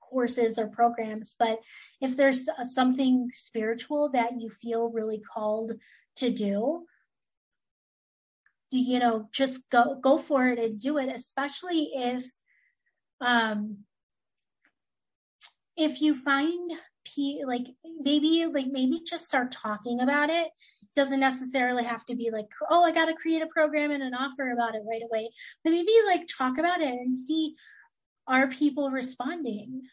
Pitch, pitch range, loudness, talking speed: 260 Hz, 235-300 Hz, -27 LUFS, 150 wpm